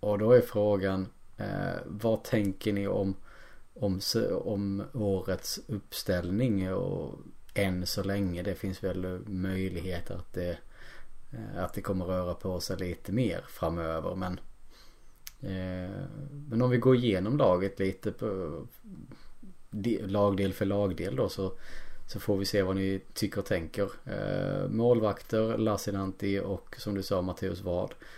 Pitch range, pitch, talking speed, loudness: 95-105 Hz, 100 Hz, 140 wpm, -31 LUFS